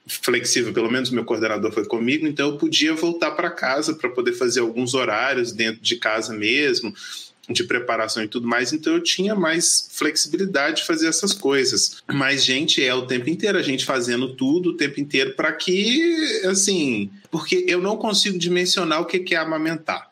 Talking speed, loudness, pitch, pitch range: 180 wpm, -20 LUFS, 160 Hz, 125-210 Hz